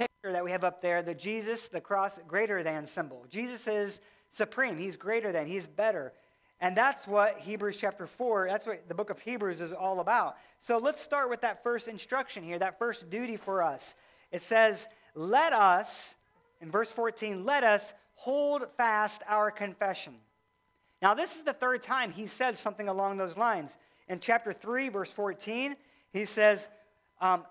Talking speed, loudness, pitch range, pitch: 175 wpm, -31 LUFS, 190-230 Hz, 210 Hz